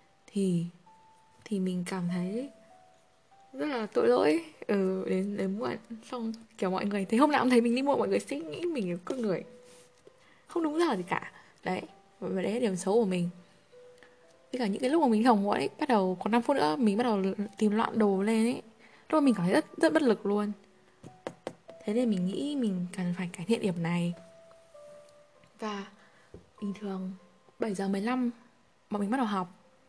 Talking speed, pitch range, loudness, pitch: 205 wpm, 185-245 Hz, -30 LUFS, 210 Hz